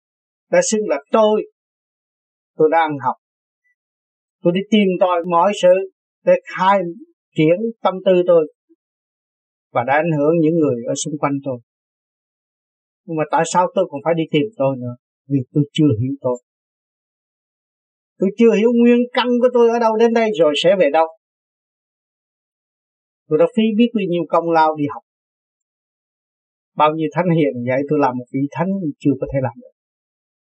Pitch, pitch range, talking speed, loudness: 170 Hz, 150-215 Hz, 165 wpm, -17 LUFS